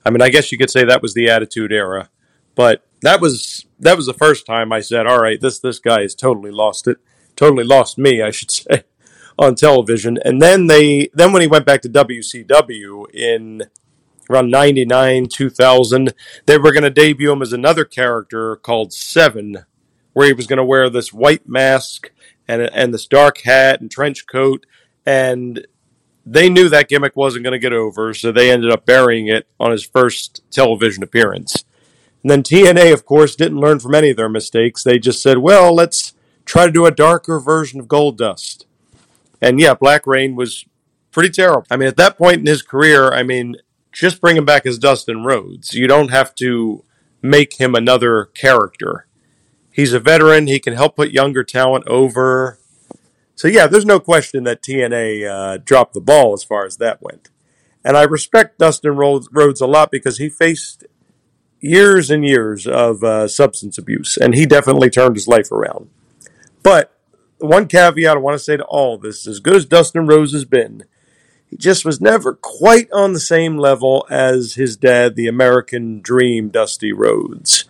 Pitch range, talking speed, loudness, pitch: 120-150 Hz, 190 wpm, -12 LUFS, 135 Hz